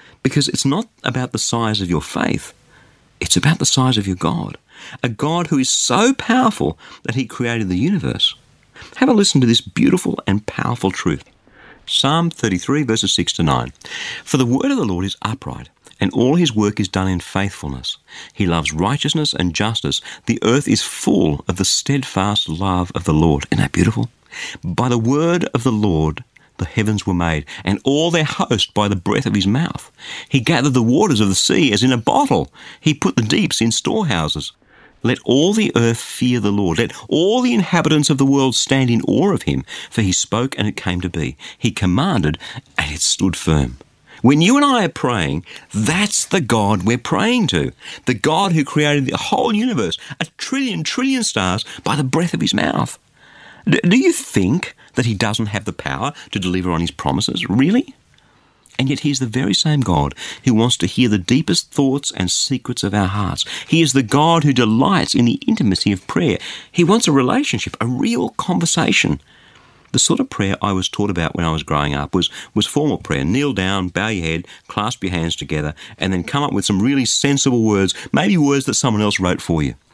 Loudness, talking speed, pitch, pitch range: -17 LUFS, 205 wpm, 120 Hz, 95-145 Hz